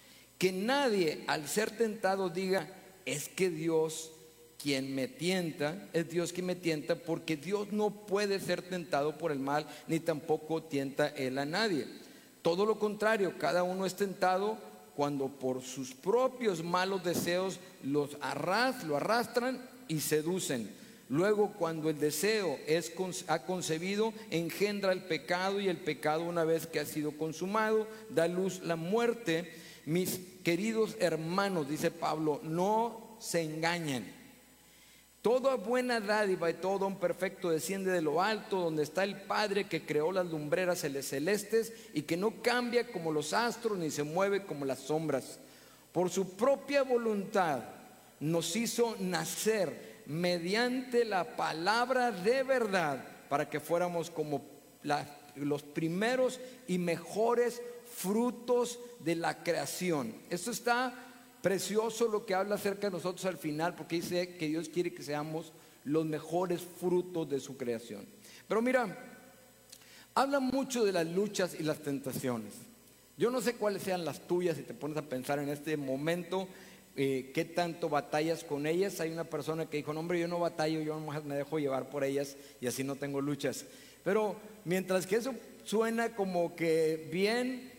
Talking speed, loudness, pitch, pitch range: 150 wpm, -33 LUFS, 175 Hz, 155-210 Hz